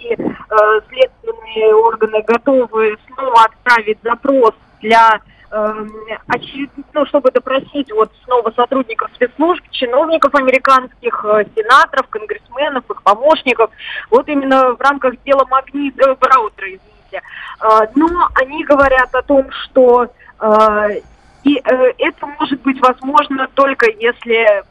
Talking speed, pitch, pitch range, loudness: 115 wpm, 265 Hz, 225-290 Hz, -13 LUFS